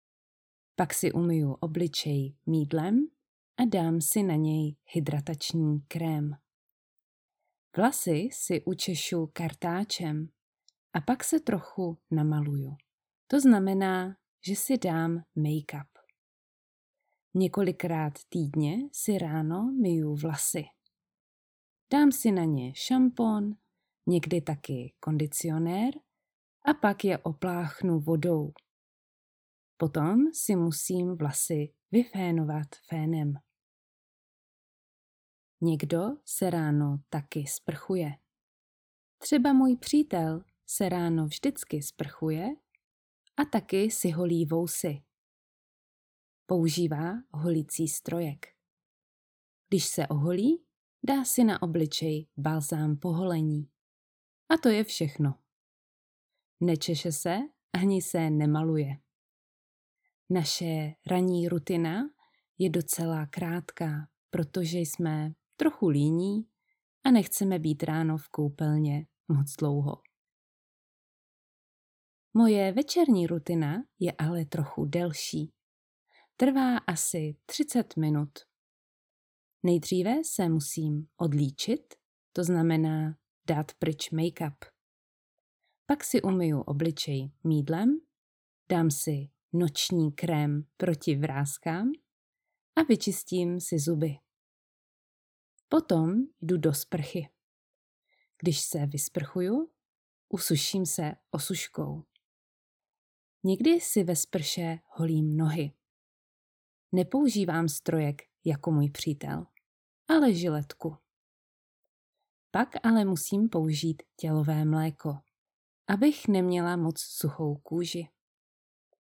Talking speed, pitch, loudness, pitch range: 90 wpm, 165 Hz, -29 LUFS, 155-190 Hz